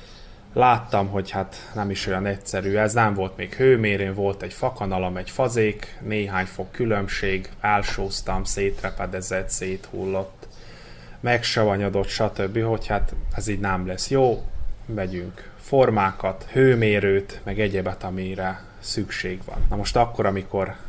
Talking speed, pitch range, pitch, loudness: 125 wpm, 95-110 Hz, 100 Hz, -24 LUFS